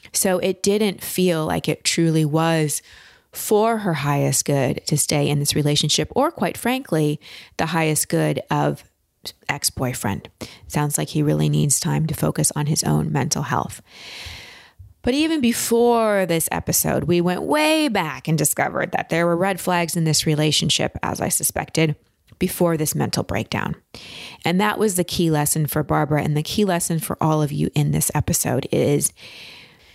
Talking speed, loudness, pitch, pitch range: 170 wpm, -20 LUFS, 155 Hz, 145-180 Hz